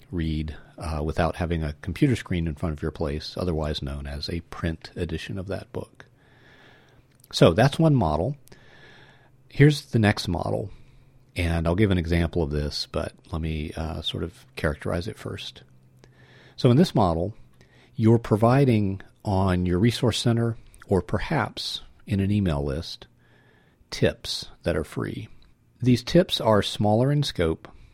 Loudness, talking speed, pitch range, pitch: -25 LUFS, 150 wpm, 80-125 Hz, 95 Hz